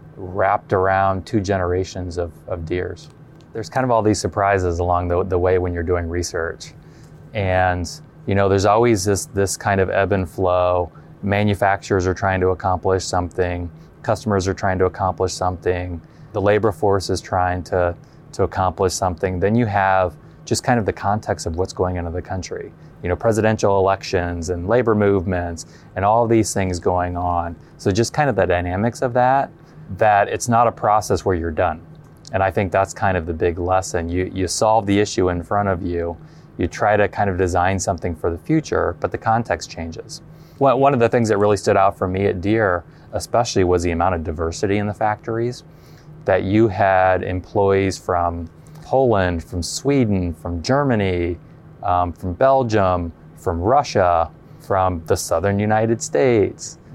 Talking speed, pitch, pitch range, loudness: 180 wpm, 95 Hz, 90-110 Hz, -19 LUFS